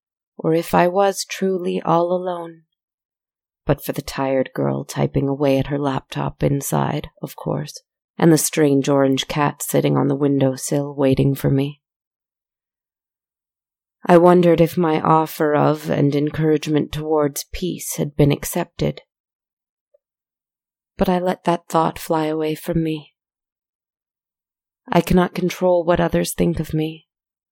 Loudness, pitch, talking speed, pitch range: -19 LUFS, 155 Hz, 135 wpm, 140-170 Hz